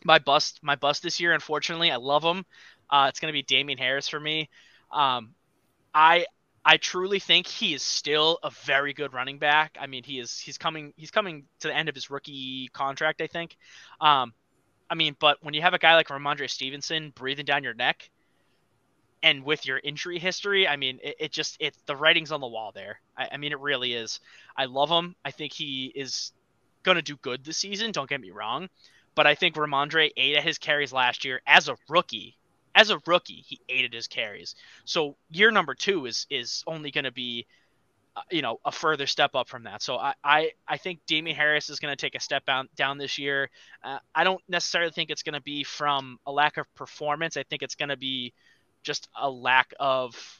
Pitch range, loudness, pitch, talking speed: 135-160 Hz, -25 LUFS, 150 Hz, 220 wpm